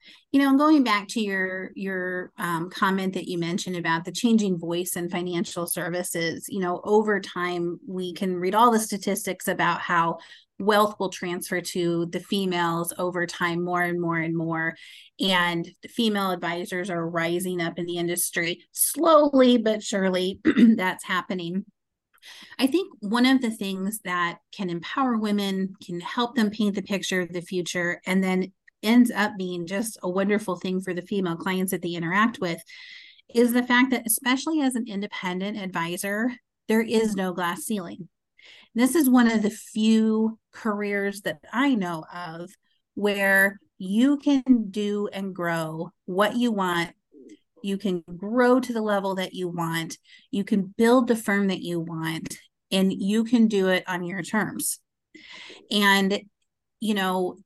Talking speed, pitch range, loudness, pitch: 165 wpm, 175-220 Hz, -24 LUFS, 195 Hz